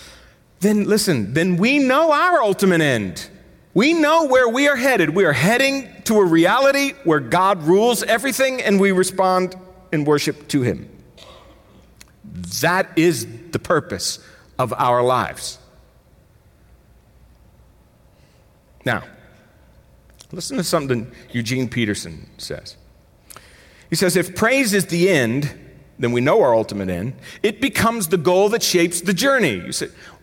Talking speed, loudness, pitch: 135 wpm, -18 LUFS, 180 Hz